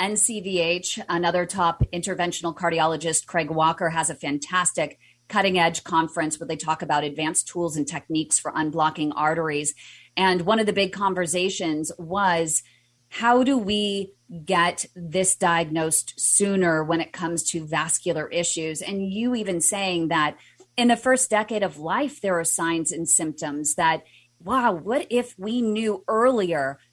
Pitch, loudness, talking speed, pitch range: 170 Hz, -23 LUFS, 150 wpm, 160-195 Hz